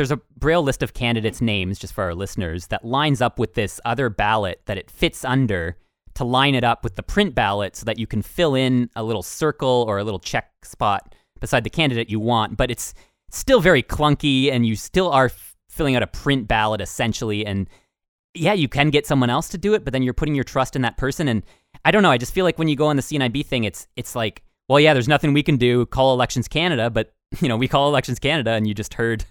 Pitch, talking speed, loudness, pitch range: 125 Hz, 250 wpm, -20 LUFS, 110-145 Hz